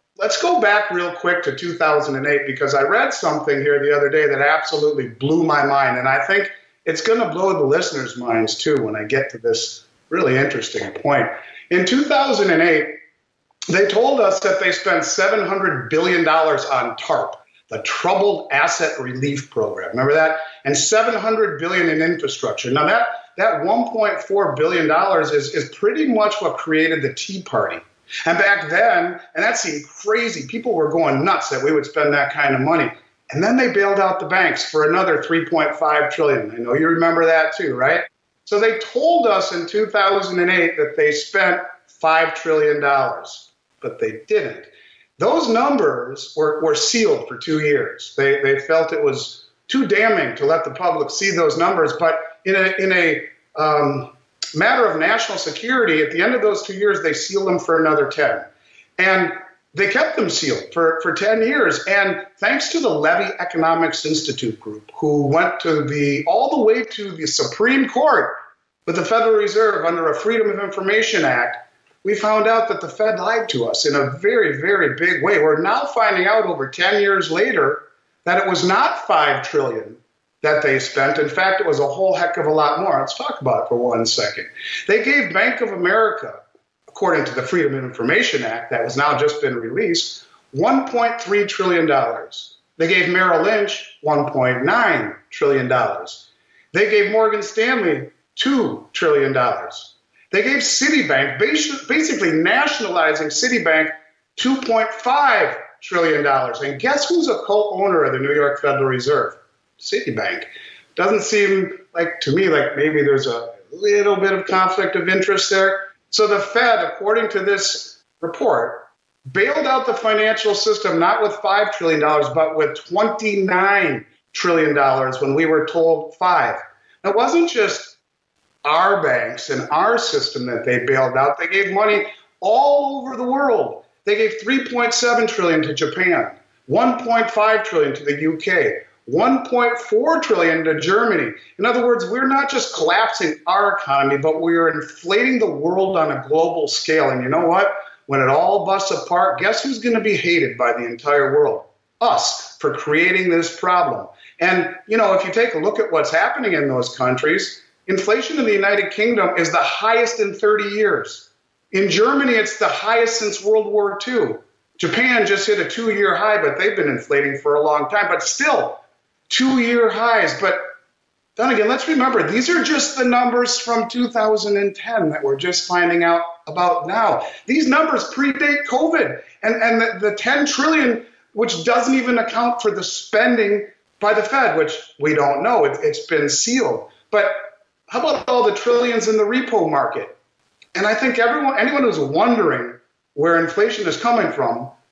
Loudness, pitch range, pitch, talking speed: -17 LUFS, 165-245 Hz, 205 Hz, 170 wpm